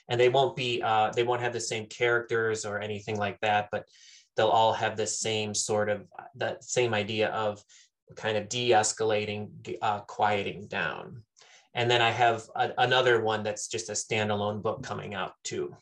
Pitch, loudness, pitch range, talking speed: 110 Hz, -28 LUFS, 105-120 Hz, 185 wpm